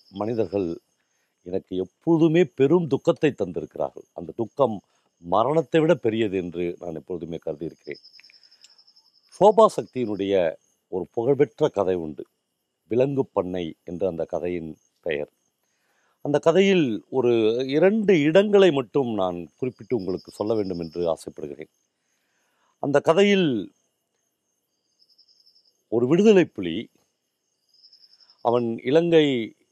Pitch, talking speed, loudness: 120 Hz, 95 wpm, -23 LUFS